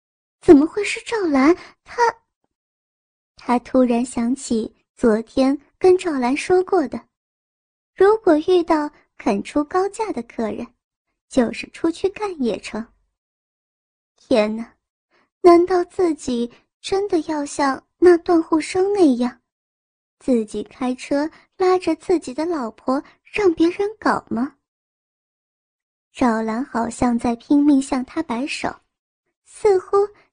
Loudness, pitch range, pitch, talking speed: -19 LUFS, 250-365 Hz, 300 Hz, 165 characters per minute